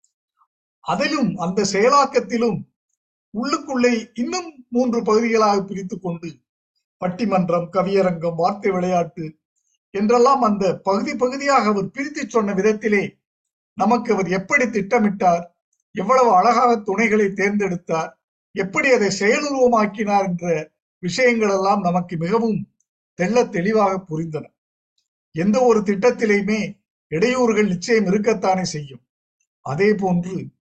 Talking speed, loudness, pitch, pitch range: 95 wpm, -19 LUFS, 205 Hz, 185-240 Hz